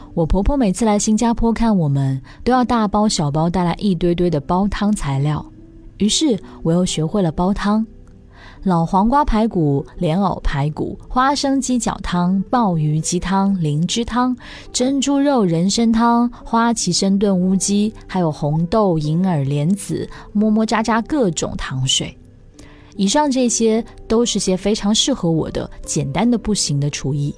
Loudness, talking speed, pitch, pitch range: -18 LUFS, 235 characters per minute, 195 Hz, 165-230 Hz